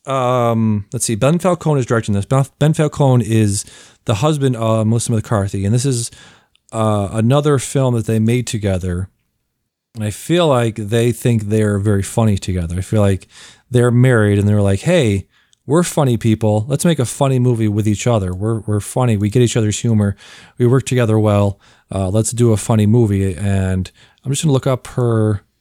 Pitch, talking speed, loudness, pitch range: 115 Hz, 190 wpm, -16 LUFS, 105-125 Hz